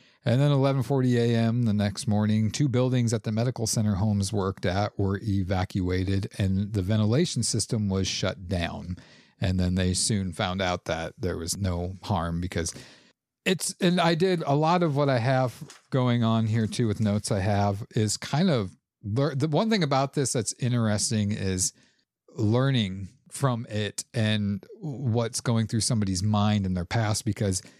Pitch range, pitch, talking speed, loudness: 100-125 Hz, 110 Hz, 175 wpm, -26 LUFS